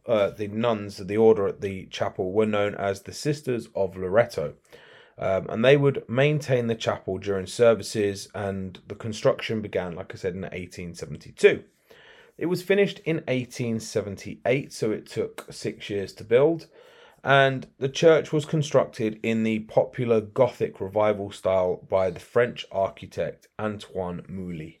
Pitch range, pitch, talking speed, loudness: 100-135 Hz, 110 Hz, 150 wpm, -25 LUFS